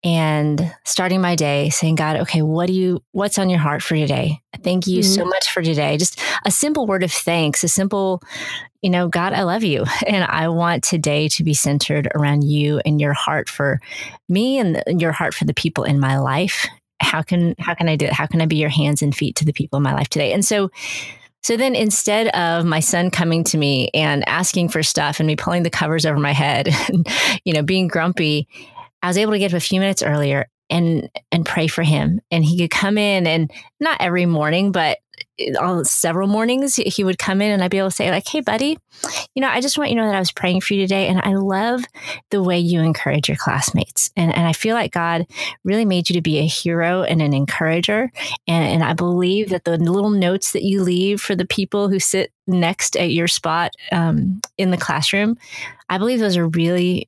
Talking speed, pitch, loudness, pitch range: 230 wpm, 175 Hz, -18 LUFS, 160-195 Hz